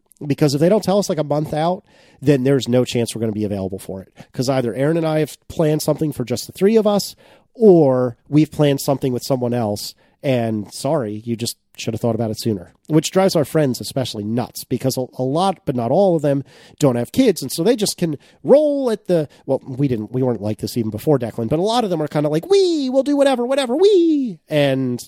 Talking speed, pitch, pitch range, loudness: 245 wpm, 145 Hz, 120-175 Hz, -18 LUFS